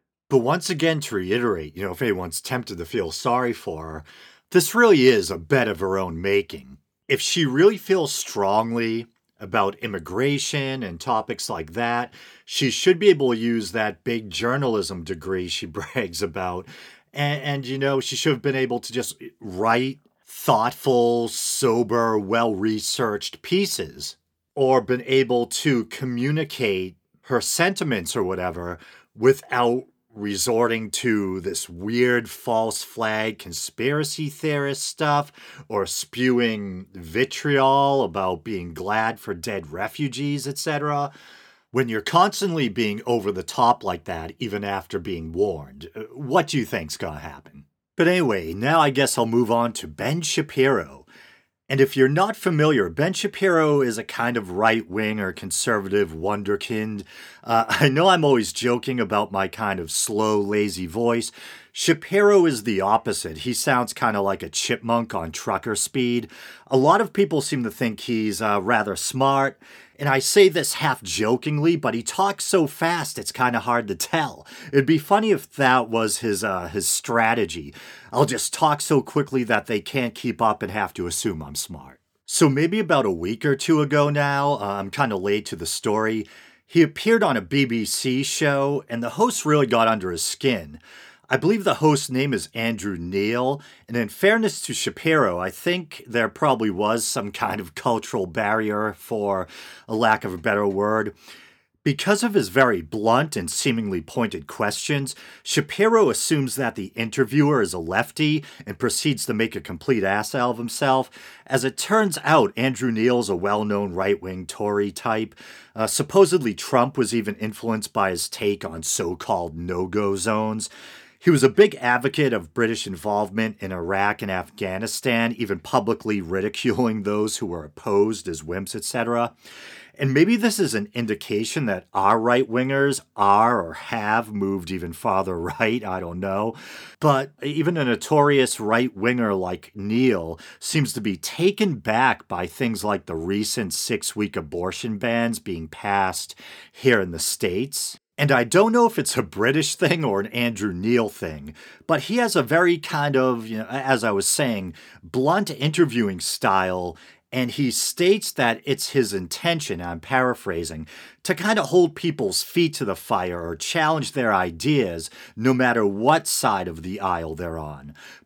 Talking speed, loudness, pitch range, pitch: 165 wpm, -22 LUFS, 100-140 Hz, 120 Hz